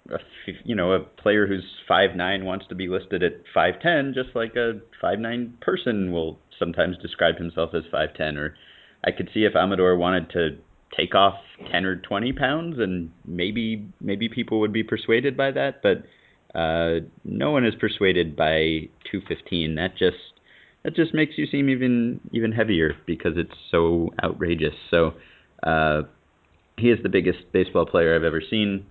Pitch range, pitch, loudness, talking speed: 80-115 Hz, 95 Hz, -23 LUFS, 165 wpm